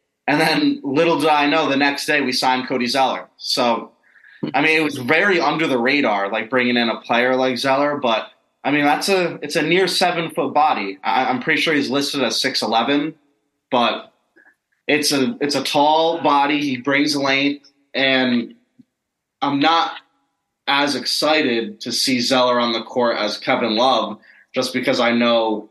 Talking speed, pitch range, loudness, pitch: 175 wpm, 125-150 Hz, -18 LUFS, 140 Hz